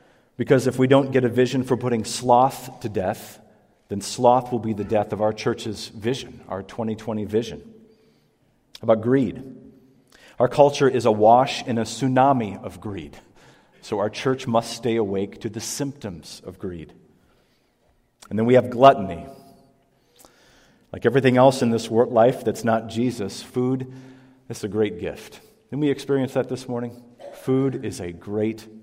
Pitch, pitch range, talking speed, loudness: 120 Hz, 110-130 Hz, 160 wpm, -22 LUFS